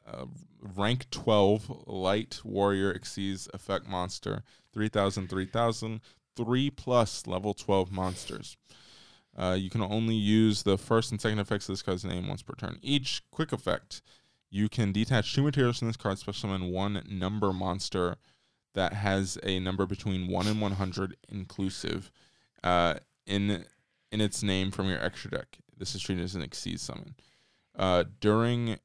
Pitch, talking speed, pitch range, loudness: 100 Hz, 160 wpm, 95-110 Hz, -31 LUFS